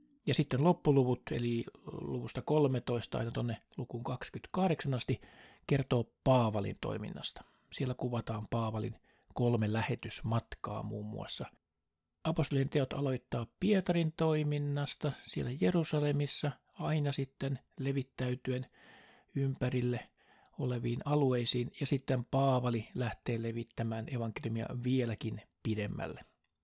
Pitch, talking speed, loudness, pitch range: 125 Hz, 95 wpm, -35 LUFS, 115-145 Hz